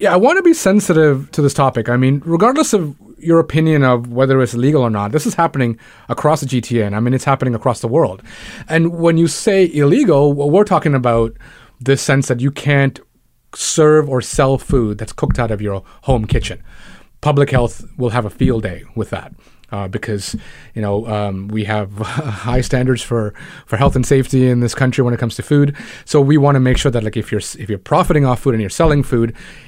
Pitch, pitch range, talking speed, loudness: 130 Hz, 115-150 Hz, 220 wpm, -15 LUFS